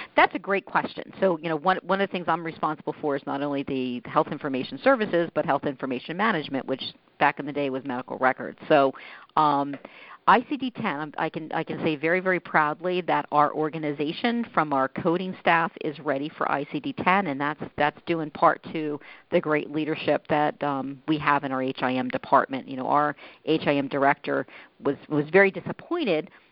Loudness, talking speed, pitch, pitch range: -25 LUFS, 190 wpm, 155 Hz, 145-175 Hz